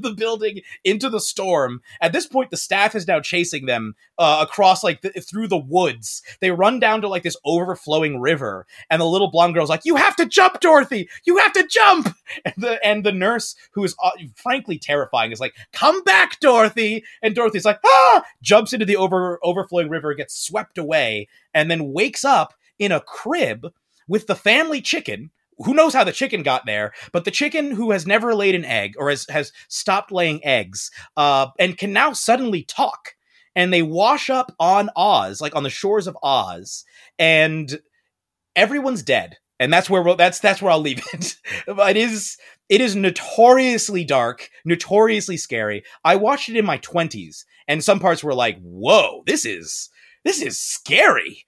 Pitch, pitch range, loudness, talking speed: 190 Hz, 155-225 Hz, -18 LUFS, 190 wpm